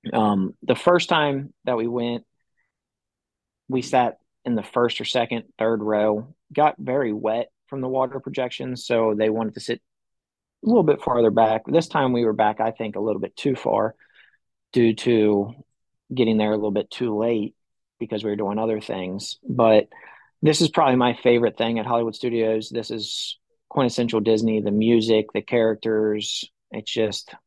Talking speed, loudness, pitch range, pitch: 175 wpm, -22 LUFS, 110-125 Hz, 115 Hz